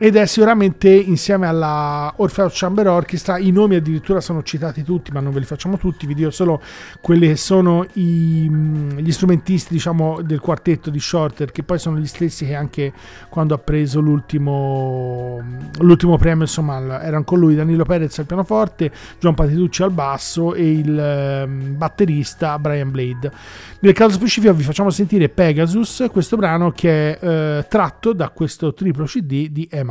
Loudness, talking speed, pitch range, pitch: -17 LUFS, 165 wpm, 150-180 Hz, 160 Hz